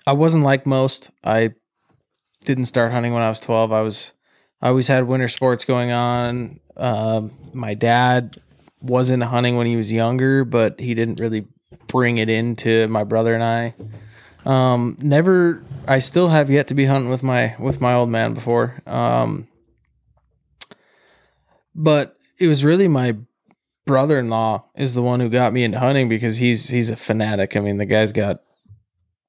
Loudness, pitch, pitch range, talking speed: -18 LUFS, 120 Hz, 115-130 Hz, 170 wpm